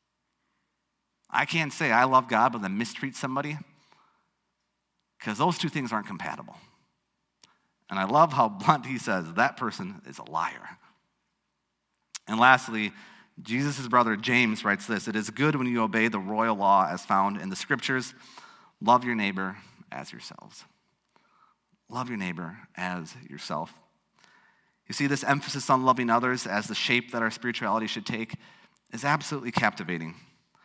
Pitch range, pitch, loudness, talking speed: 110-140 Hz, 125 Hz, -26 LUFS, 150 wpm